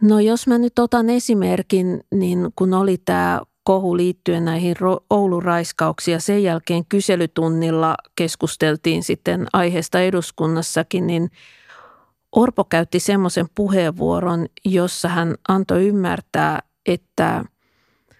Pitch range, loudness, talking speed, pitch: 170-195 Hz, -19 LUFS, 105 wpm, 180 Hz